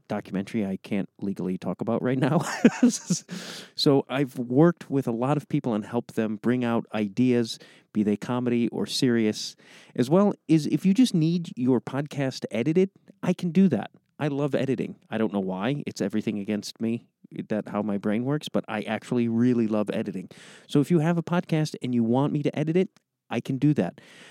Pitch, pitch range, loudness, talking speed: 130 Hz, 115-160 Hz, -26 LUFS, 200 wpm